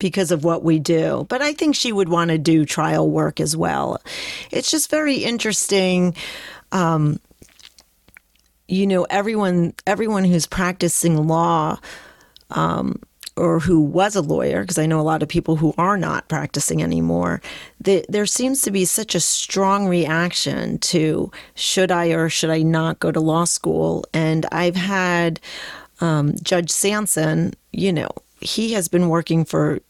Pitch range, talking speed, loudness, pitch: 160-195 Hz, 160 wpm, -19 LUFS, 170 Hz